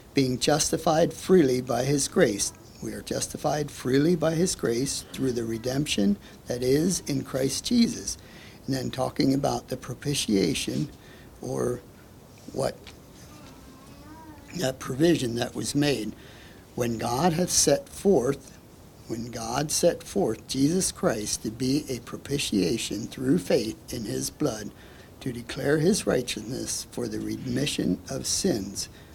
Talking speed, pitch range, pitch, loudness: 130 wpm, 120-150 Hz, 135 Hz, -26 LUFS